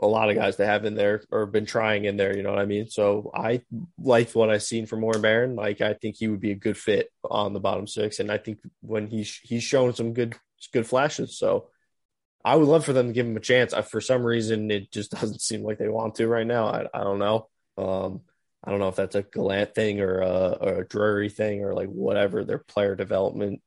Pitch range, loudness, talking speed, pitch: 105-115 Hz, -25 LUFS, 260 wpm, 110 Hz